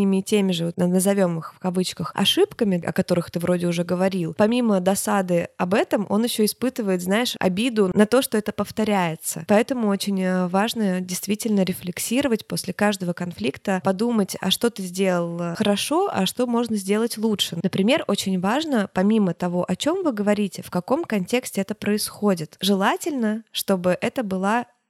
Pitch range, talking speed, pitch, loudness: 185-225 Hz, 155 wpm, 200 Hz, -22 LUFS